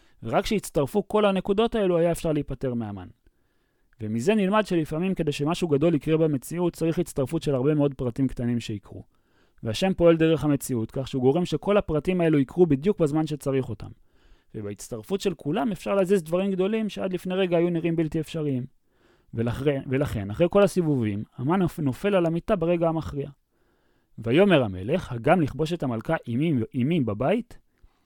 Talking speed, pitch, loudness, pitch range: 155 wpm, 155 Hz, -25 LUFS, 130-180 Hz